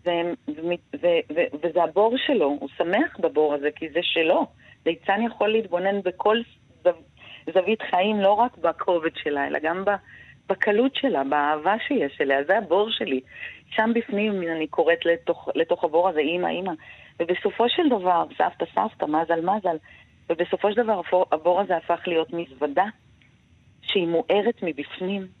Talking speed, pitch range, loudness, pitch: 150 wpm, 160-210 Hz, -24 LUFS, 175 Hz